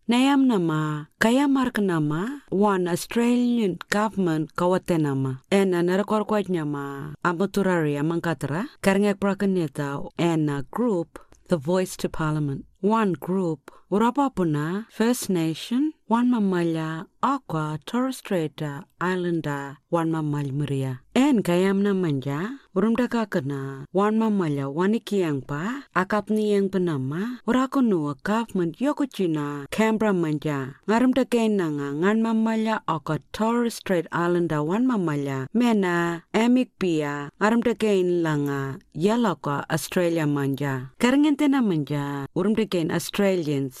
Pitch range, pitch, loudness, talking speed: 155-220 Hz, 180 Hz, -24 LUFS, 105 wpm